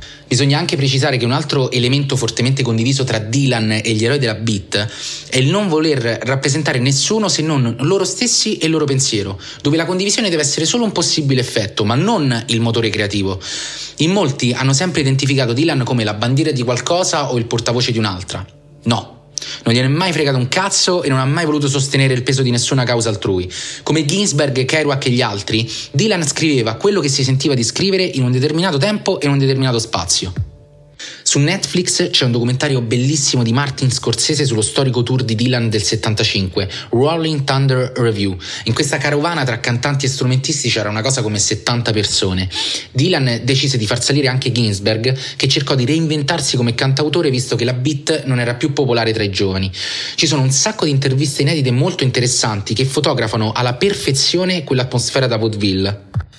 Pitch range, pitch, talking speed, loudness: 115-150 Hz, 130 Hz, 185 wpm, -16 LUFS